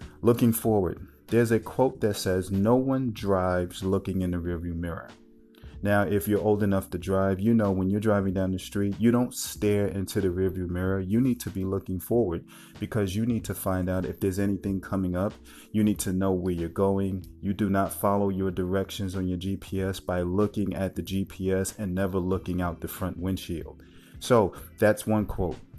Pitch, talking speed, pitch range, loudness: 95 Hz, 200 wpm, 90-105 Hz, -27 LUFS